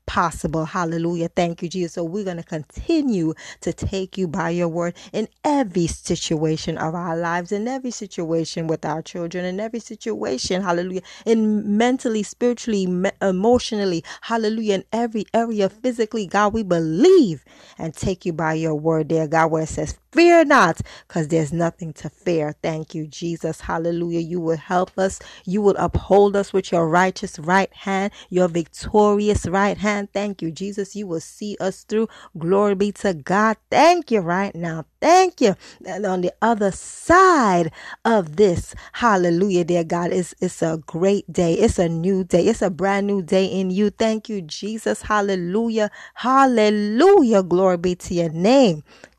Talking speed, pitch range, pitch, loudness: 165 wpm, 170-215 Hz, 190 Hz, -20 LUFS